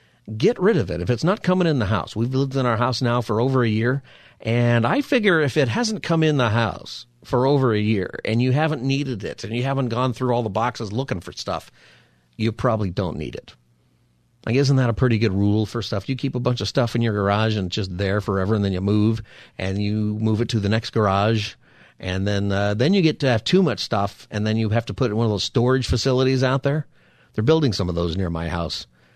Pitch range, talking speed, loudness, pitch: 100-130 Hz, 255 wpm, -21 LUFS, 115 Hz